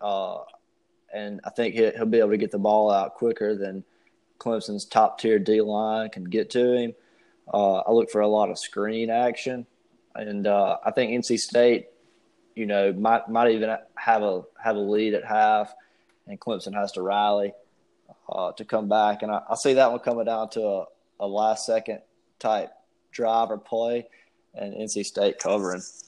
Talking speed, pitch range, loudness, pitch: 185 wpm, 105-115 Hz, -24 LUFS, 110 Hz